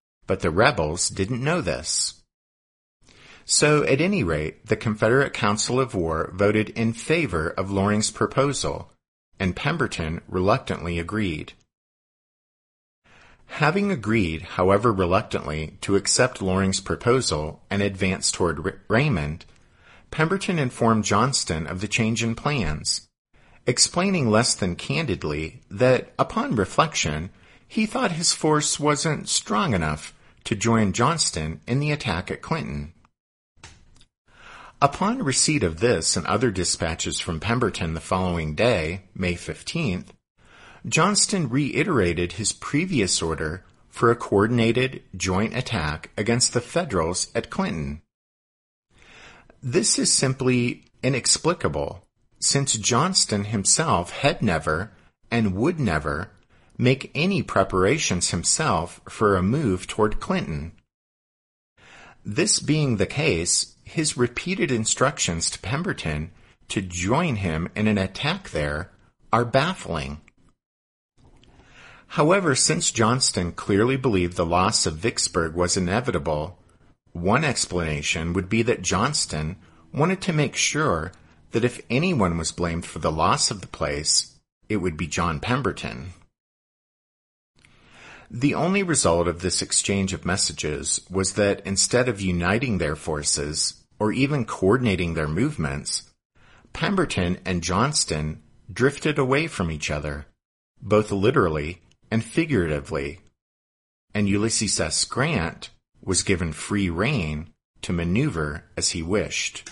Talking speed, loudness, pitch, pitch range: 120 wpm, -23 LUFS, 100 Hz, 85-125 Hz